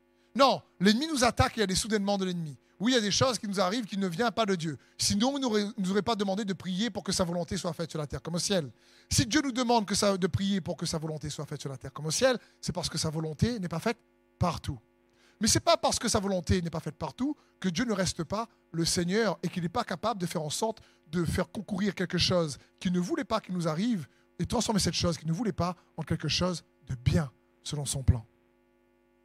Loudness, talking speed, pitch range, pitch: -30 LUFS, 270 wpm, 160-215 Hz, 180 Hz